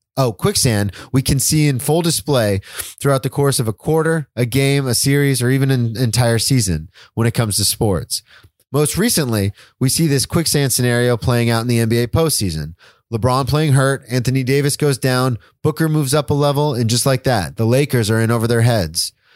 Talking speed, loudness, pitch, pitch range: 200 wpm, -16 LUFS, 130 Hz, 115-140 Hz